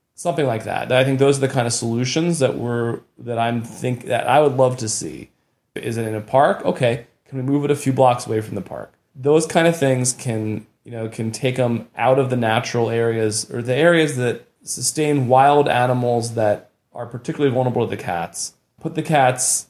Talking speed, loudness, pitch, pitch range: 215 wpm, -19 LUFS, 125 Hz, 115-135 Hz